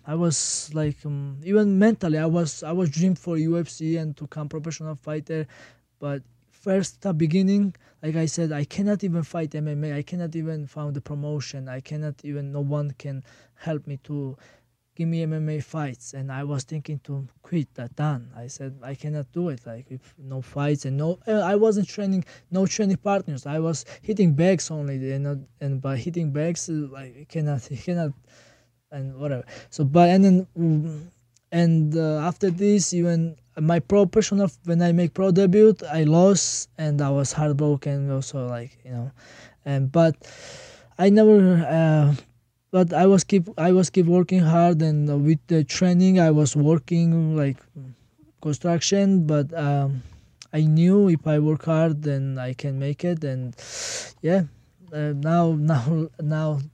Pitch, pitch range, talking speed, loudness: 155 Hz, 140-170 Hz, 170 wpm, -23 LUFS